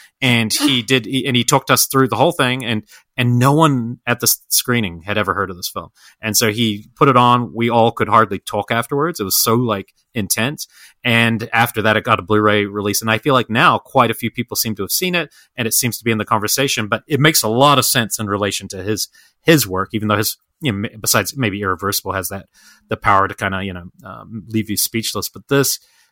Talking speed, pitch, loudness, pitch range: 250 wpm, 115 Hz, -16 LUFS, 105-125 Hz